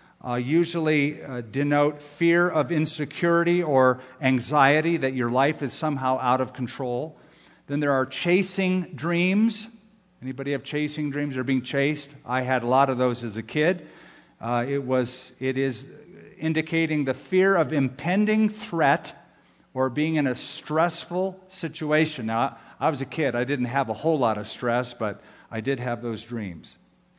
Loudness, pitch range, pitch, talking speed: -25 LUFS, 130-160 Hz, 140 Hz, 165 wpm